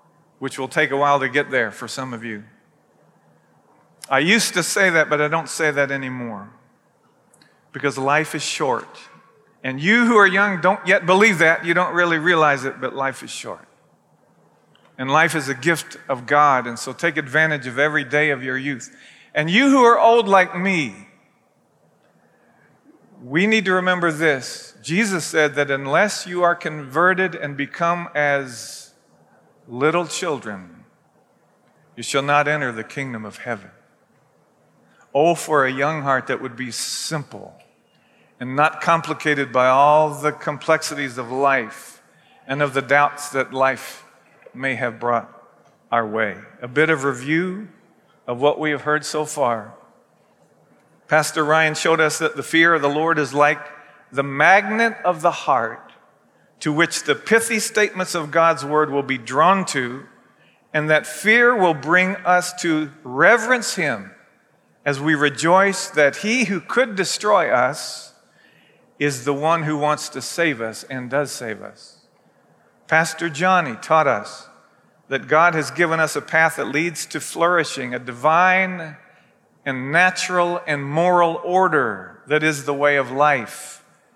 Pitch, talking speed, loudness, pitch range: 150 Hz, 160 wpm, -19 LUFS, 140-170 Hz